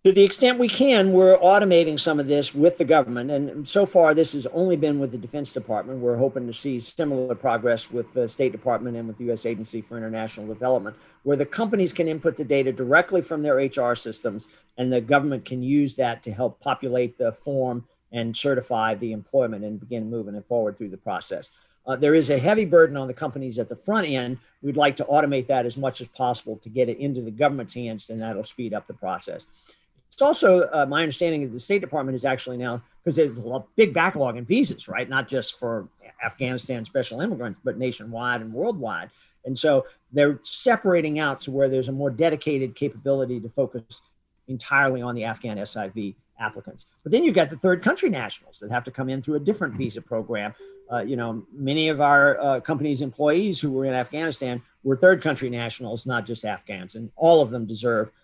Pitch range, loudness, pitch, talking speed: 120-155 Hz, -23 LUFS, 130 Hz, 210 wpm